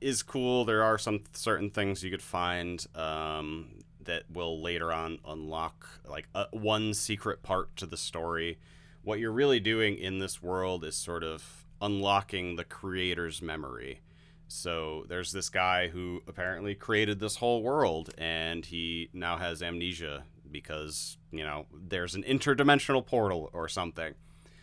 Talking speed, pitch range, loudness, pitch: 150 wpm, 80-100 Hz, -32 LUFS, 90 Hz